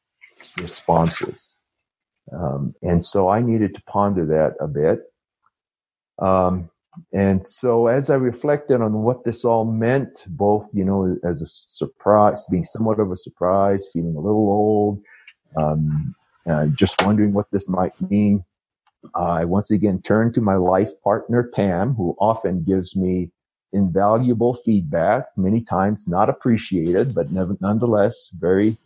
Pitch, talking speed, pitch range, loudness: 100 Hz, 140 wpm, 90-110 Hz, -20 LUFS